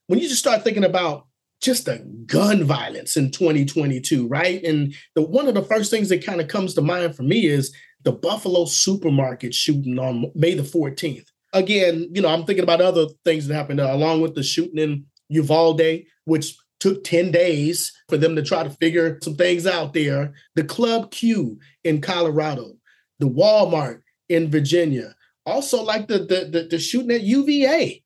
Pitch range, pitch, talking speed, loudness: 150-185 Hz, 165 Hz, 180 wpm, -20 LUFS